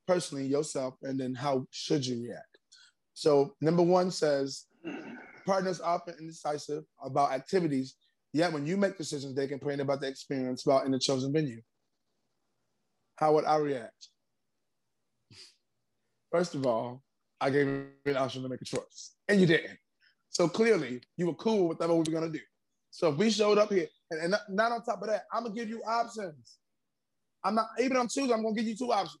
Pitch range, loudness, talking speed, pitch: 140-210 Hz, -30 LUFS, 195 wpm, 160 Hz